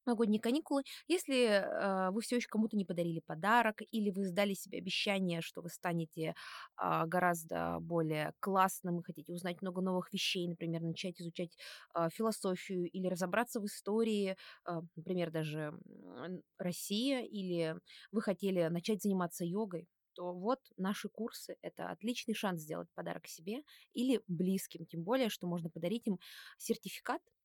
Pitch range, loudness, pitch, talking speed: 175-220 Hz, -37 LUFS, 190 Hz, 145 wpm